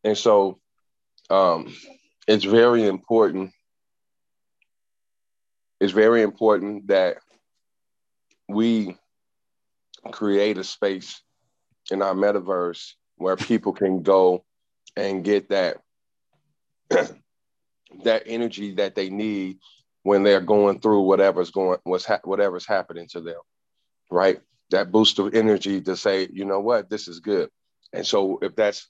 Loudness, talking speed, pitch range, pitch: -22 LUFS, 120 wpm, 95-110 Hz, 100 Hz